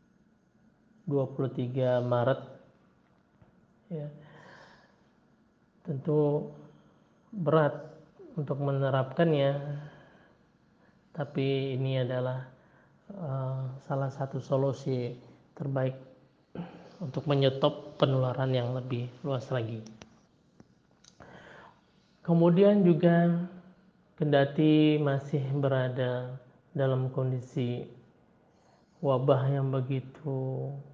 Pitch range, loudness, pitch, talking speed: 130-155 Hz, -29 LUFS, 140 Hz, 60 wpm